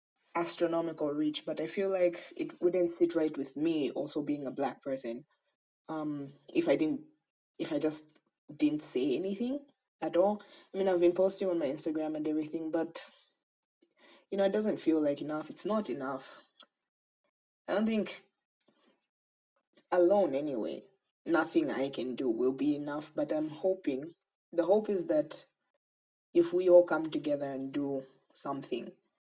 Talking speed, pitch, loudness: 160 wpm, 180 Hz, -32 LUFS